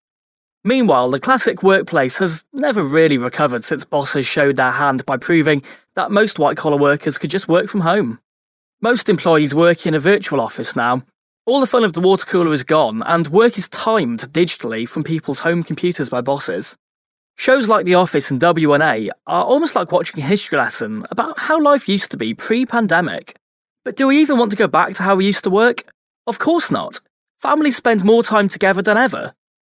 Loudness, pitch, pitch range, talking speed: -16 LUFS, 180 Hz, 150-225 Hz, 195 wpm